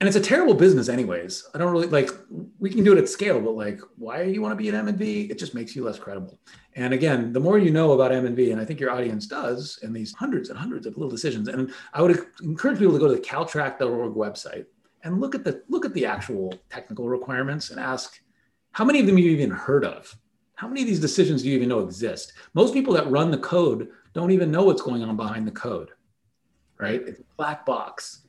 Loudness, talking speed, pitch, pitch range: -23 LUFS, 250 wpm, 140 Hz, 125-190 Hz